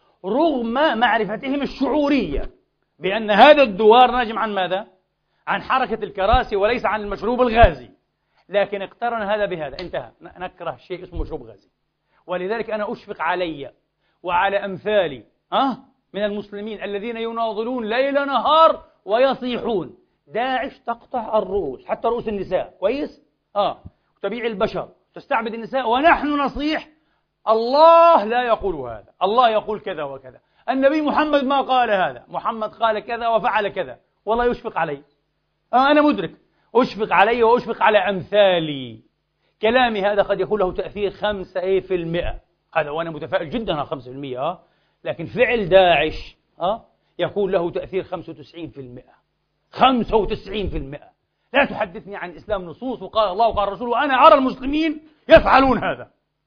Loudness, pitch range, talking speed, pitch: -19 LUFS, 190-250 Hz, 135 wpm, 220 Hz